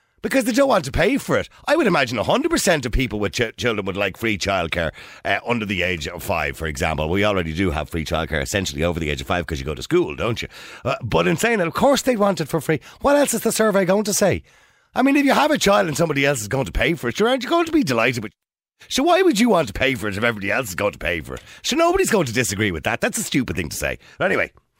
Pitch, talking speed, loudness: 130 Hz, 305 wpm, -20 LUFS